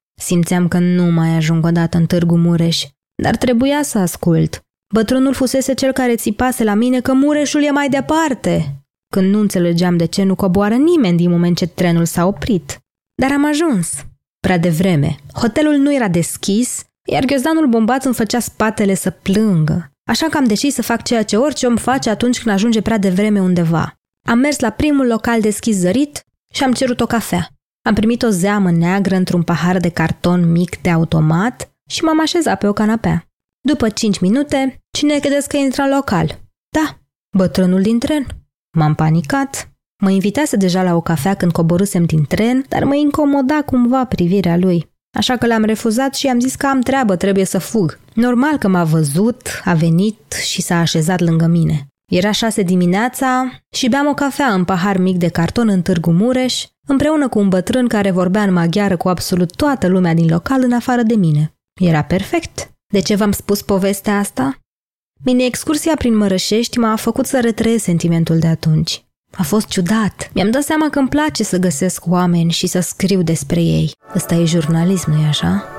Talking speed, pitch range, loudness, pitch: 185 wpm, 175-255 Hz, -15 LUFS, 200 Hz